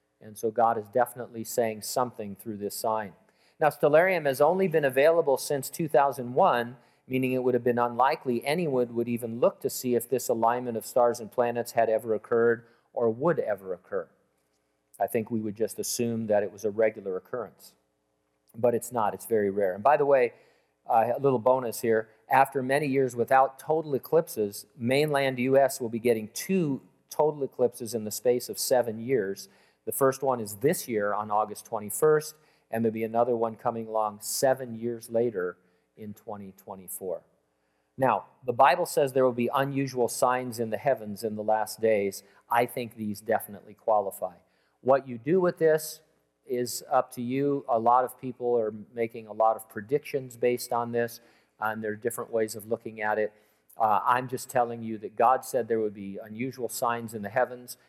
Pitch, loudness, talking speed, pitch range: 120 Hz, -27 LUFS, 185 wpm, 110-130 Hz